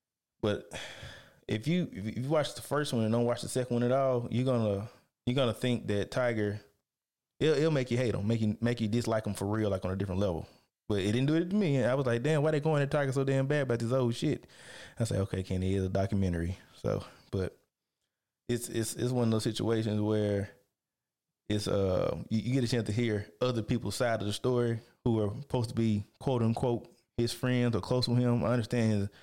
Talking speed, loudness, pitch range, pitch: 240 wpm, -31 LUFS, 105-125 Hz, 115 Hz